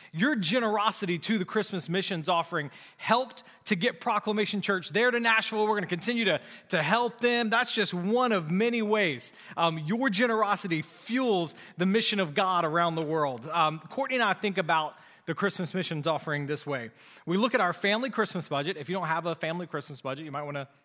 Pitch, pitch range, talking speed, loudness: 190 Hz, 165-220 Hz, 205 wpm, -28 LUFS